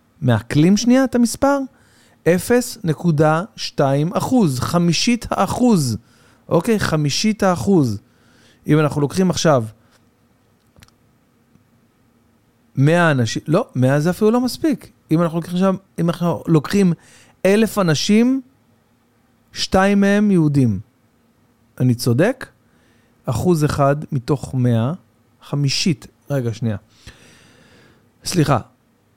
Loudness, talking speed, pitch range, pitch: -18 LUFS, 85 wpm, 120-180 Hz, 140 Hz